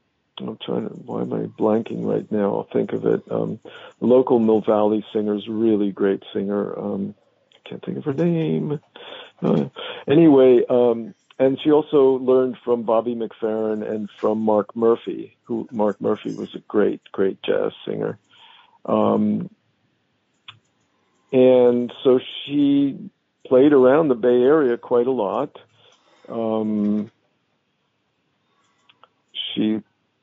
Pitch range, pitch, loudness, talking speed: 110-160 Hz, 120 Hz, -20 LUFS, 130 wpm